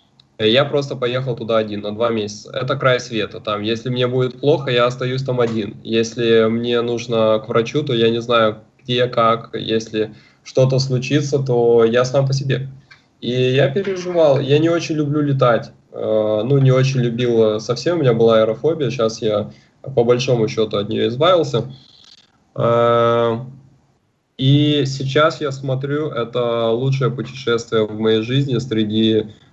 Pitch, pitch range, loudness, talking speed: 120 Hz, 115-135 Hz, -18 LUFS, 150 wpm